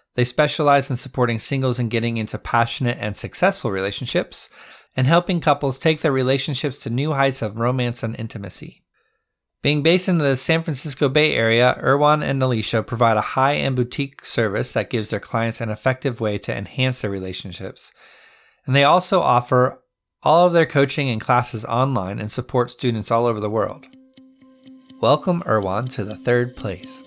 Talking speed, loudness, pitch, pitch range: 170 wpm, -20 LUFS, 130 Hz, 115-145 Hz